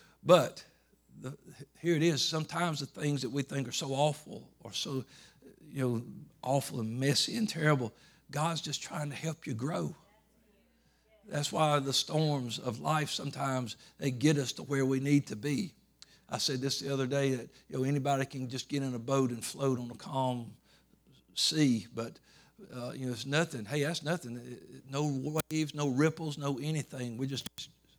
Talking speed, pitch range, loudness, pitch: 180 wpm, 130-150 Hz, -33 LUFS, 140 Hz